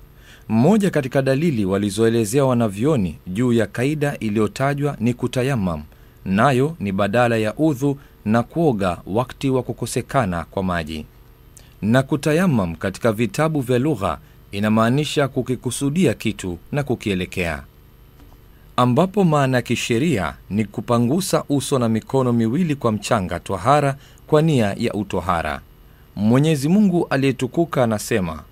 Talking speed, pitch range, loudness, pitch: 115 wpm, 105-140 Hz, -20 LUFS, 125 Hz